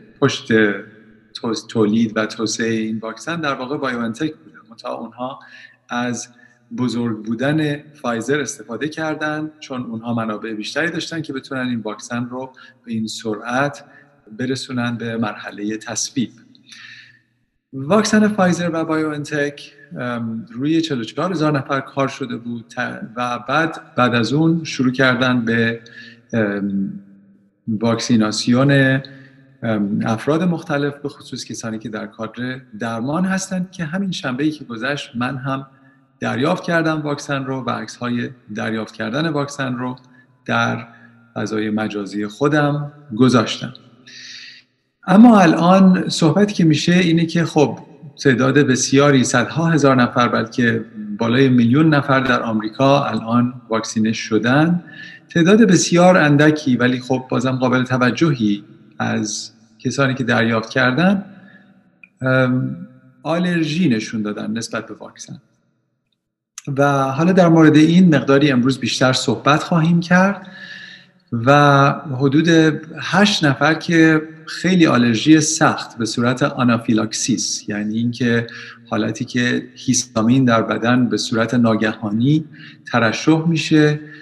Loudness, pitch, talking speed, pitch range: -17 LUFS, 130 Hz, 115 wpm, 115-150 Hz